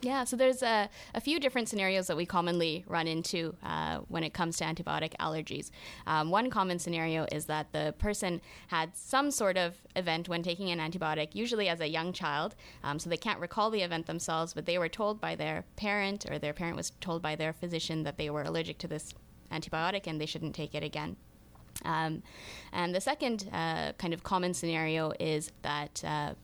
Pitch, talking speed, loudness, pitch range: 165 Hz, 205 wpm, -33 LUFS, 155-190 Hz